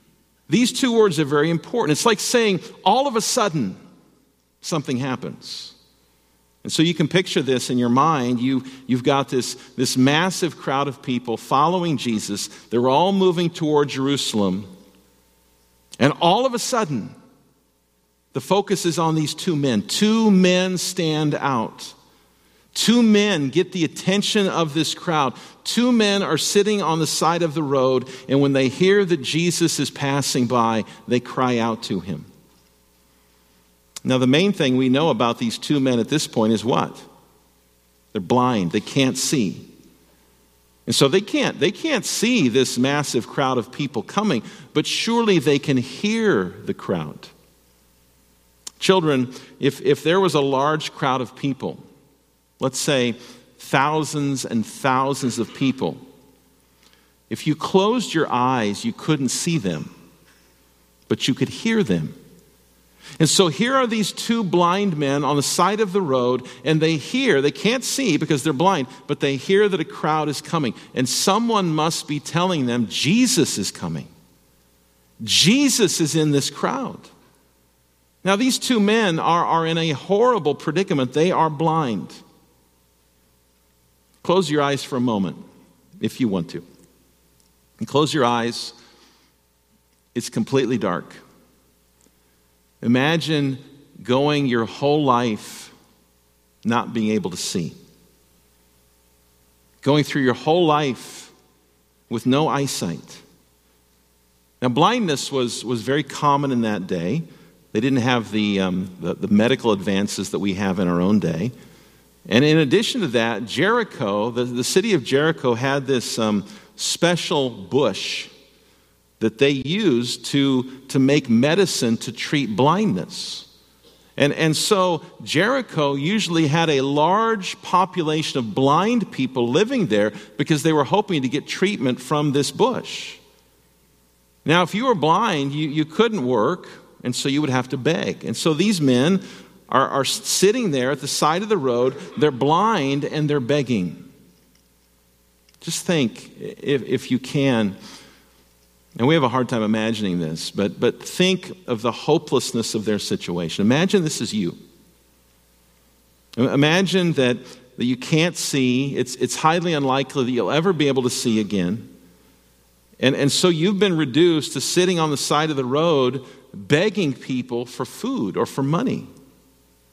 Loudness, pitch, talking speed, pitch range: -20 LUFS, 140 Hz, 150 wpm, 110-165 Hz